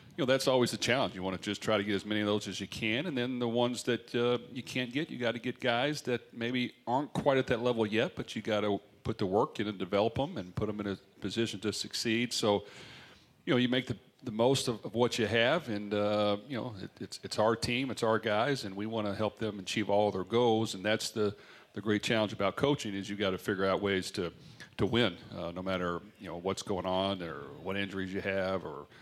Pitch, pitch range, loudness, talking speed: 105 Hz, 100-120 Hz, -32 LUFS, 265 wpm